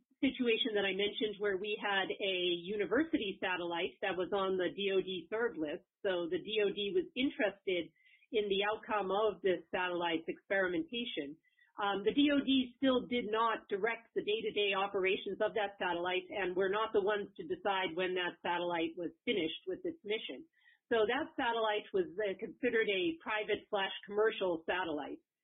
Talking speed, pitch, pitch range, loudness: 160 wpm, 210 Hz, 190-235 Hz, -35 LUFS